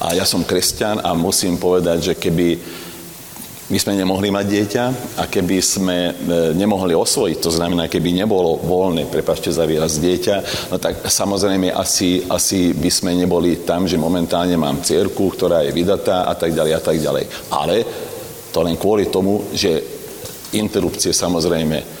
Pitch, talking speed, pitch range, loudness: 90 Hz, 160 wpm, 85-100 Hz, -17 LUFS